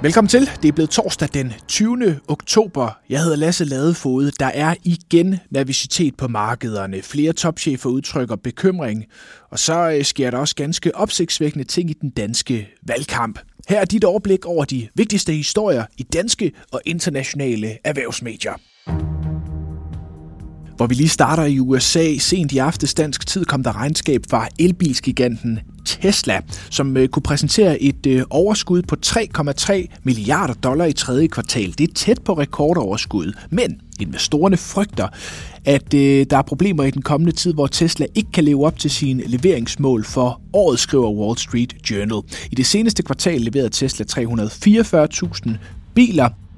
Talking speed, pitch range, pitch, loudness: 150 wpm, 120-170 Hz, 140 Hz, -18 LUFS